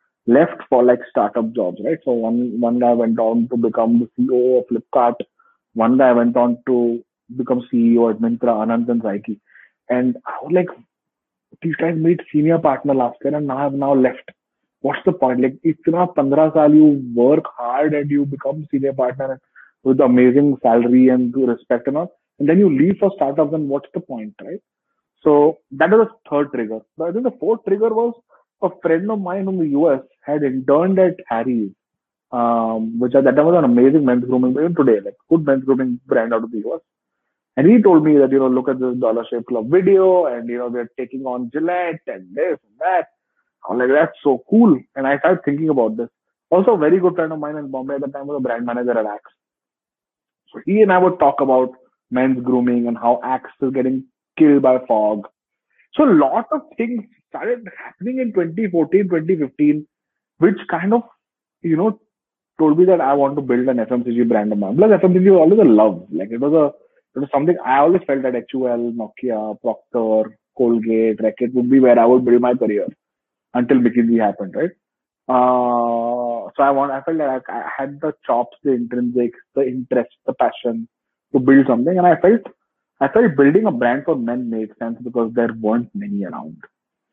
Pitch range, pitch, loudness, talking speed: 120-165 Hz, 130 Hz, -17 LUFS, 205 wpm